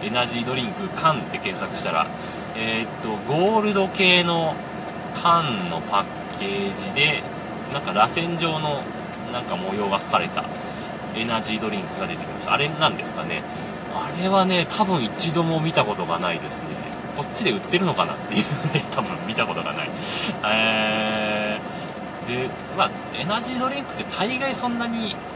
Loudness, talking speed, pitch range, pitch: -23 LUFS, 330 characters per minute, 160-190 Hz, 180 Hz